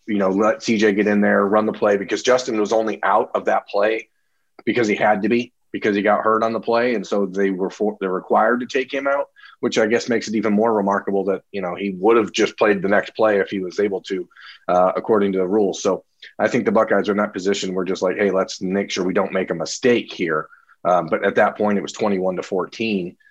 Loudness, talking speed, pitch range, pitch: -20 LUFS, 265 wpm, 95-110 Hz, 105 Hz